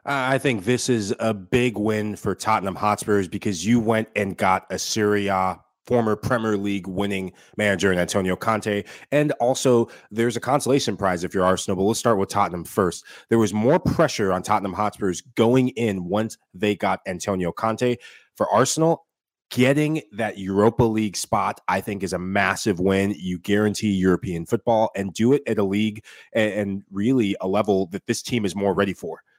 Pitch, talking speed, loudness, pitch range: 105 Hz, 180 wpm, -22 LUFS, 100-115 Hz